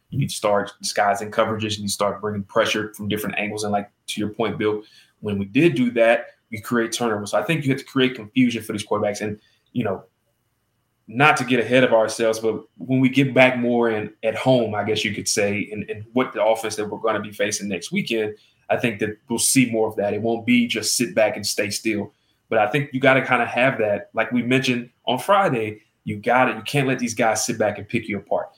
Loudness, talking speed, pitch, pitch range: -21 LUFS, 250 wpm, 110 Hz, 105-125 Hz